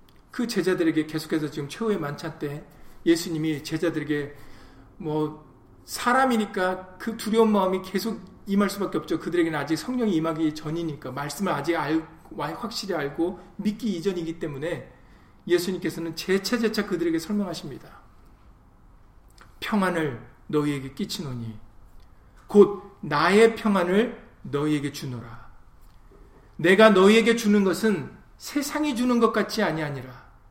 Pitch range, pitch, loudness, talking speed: 140-200 Hz, 165 Hz, -25 LUFS, 300 characters per minute